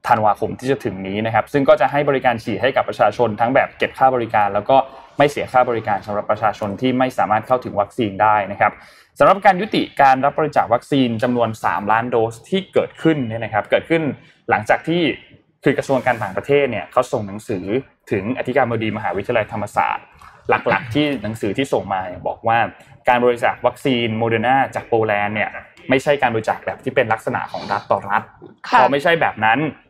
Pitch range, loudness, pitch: 110-135 Hz, -18 LUFS, 125 Hz